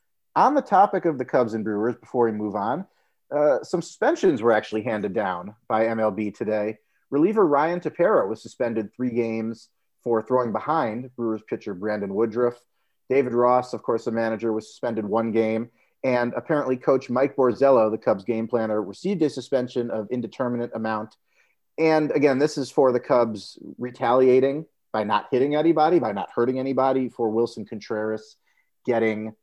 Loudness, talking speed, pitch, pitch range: -23 LUFS, 165 wpm, 120 Hz, 110-130 Hz